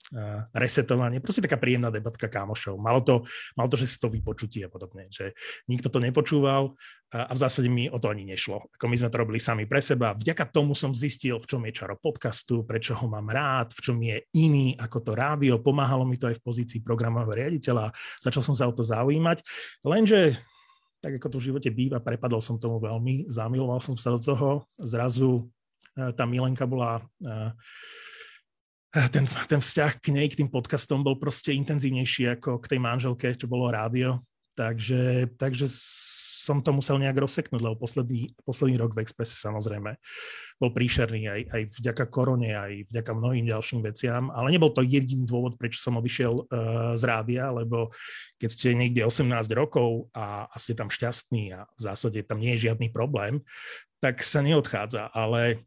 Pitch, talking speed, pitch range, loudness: 125 Hz, 180 wpm, 115-135 Hz, -27 LUFS